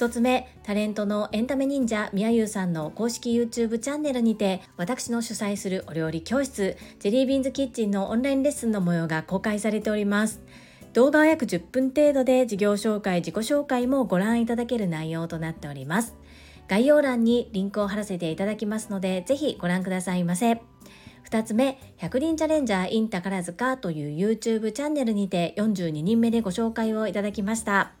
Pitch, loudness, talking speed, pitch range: 220 Hz, -25 LUFS, 415 characters per minute, 190-245 Hz